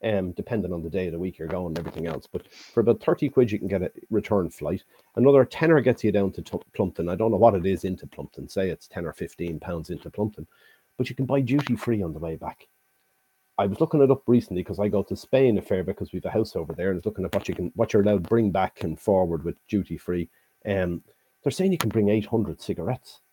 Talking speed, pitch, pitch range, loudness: 270 wpm, 100 Hz, 90-120 Hz, -25 LUFS